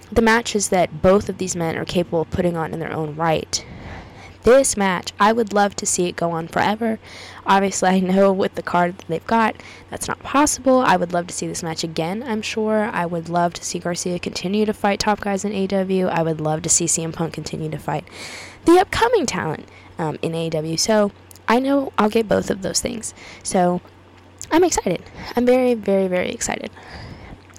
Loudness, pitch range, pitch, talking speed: -20 LUFS, 170-215 Hz, 190 Hz, 205 wpm